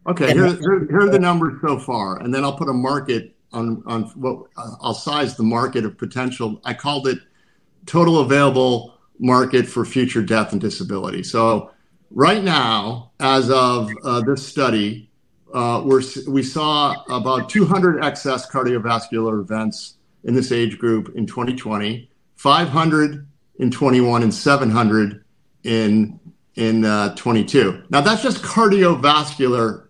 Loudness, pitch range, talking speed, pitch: -18 LUFS, 115-145 Hz, 155 wpm, 130 Hz